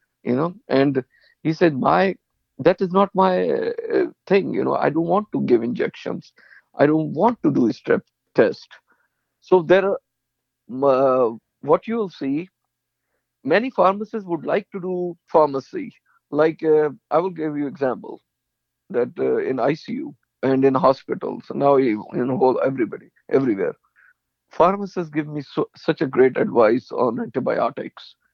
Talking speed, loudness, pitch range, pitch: 155 wpm, -21 LUFS, 140-200 Hz, 165 Hz